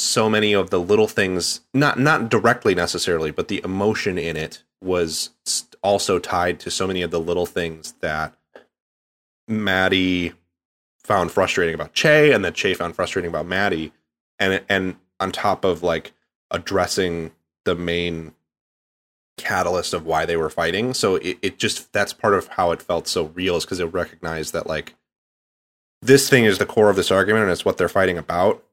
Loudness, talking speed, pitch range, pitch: -20 LUFS, 180 wpm, 80-95 Hz, 85 Hz